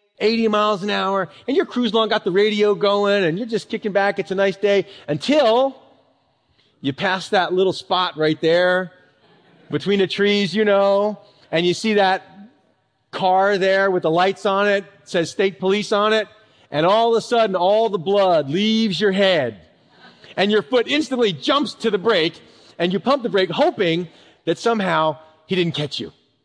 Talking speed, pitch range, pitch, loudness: 185 wpm, 180-215 Hz, 200 Hz, -19 LUFS